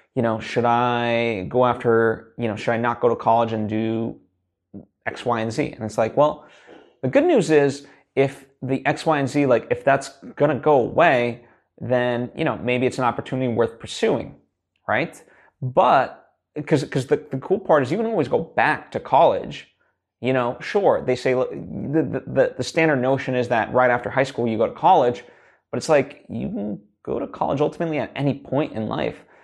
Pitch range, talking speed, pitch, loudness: 115-140 Hz, 205 wpm, 125 Hz, -21 LUFS